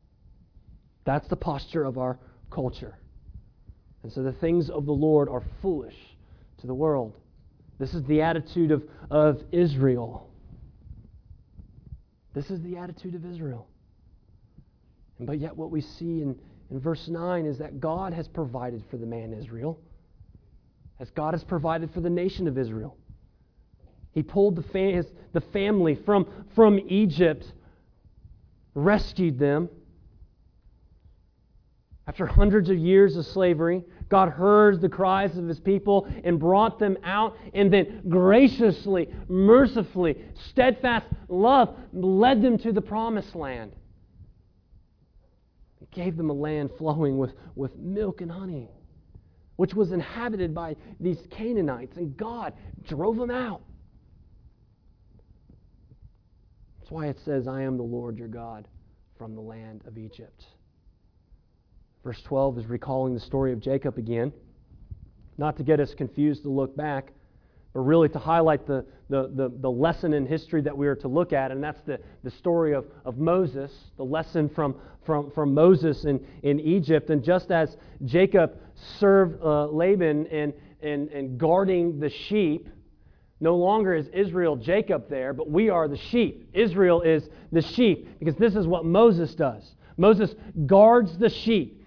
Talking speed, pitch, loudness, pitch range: 145 wpm, 150 Hz, -24 LUFS, 120-180 Hz